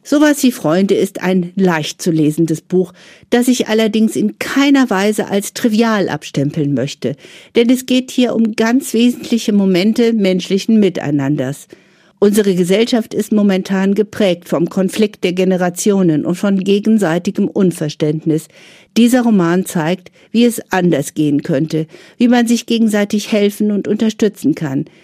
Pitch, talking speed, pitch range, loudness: 200 Hz, 140 wpm, 175-225 Hz, -14 LUFS